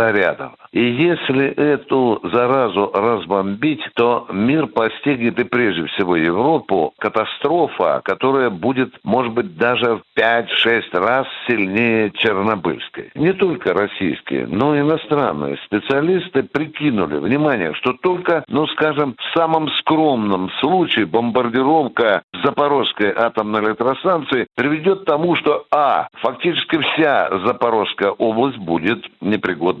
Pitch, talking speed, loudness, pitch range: 130 Hz, 110 wpm, -17 LUFS, 115-150 Hz